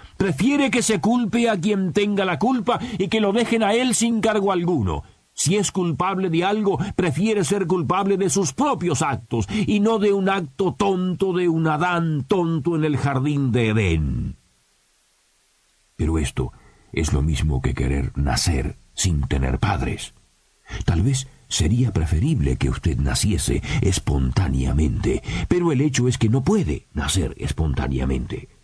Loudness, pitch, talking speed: -21 LUFS, 170 Hz, 155 wpm